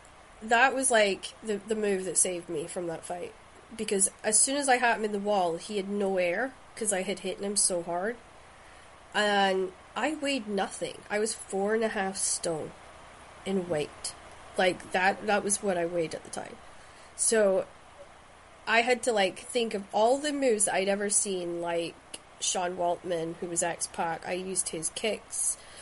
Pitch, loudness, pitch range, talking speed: 200 Hz, -28 LUFS, 180-220 Hz, 185 wpm